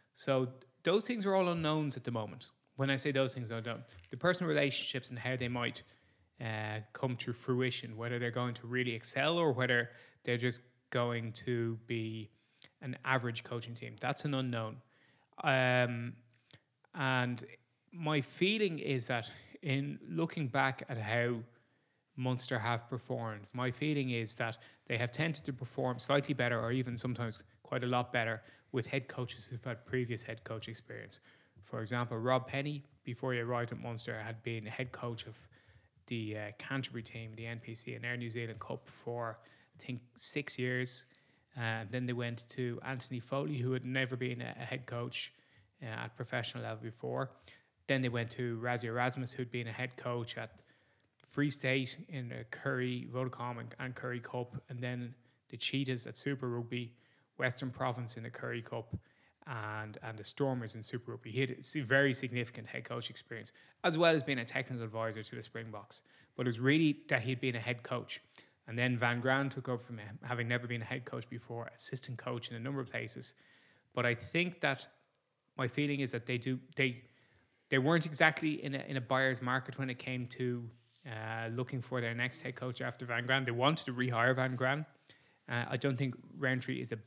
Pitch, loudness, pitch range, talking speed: 125 Hz, -37 LUFS, 120-130 Hz, 195 wpm